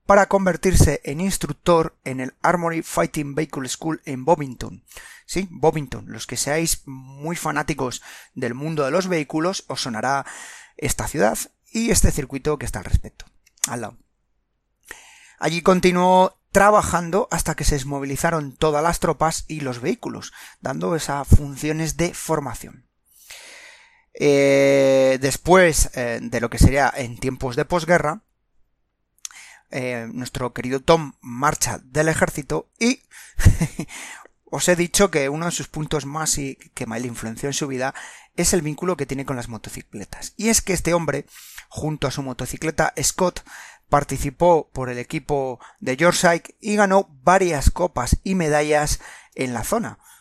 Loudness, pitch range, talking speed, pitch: -21 LUFS, 135-170 Hz, 150 wpm, 150 Hz